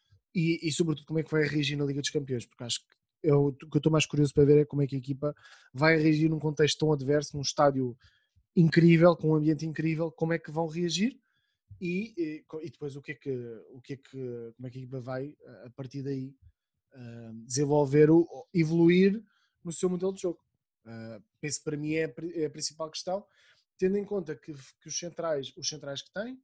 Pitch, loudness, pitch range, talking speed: 155 Hz, -28 LUFS, 140-165 Hz, 225 wpm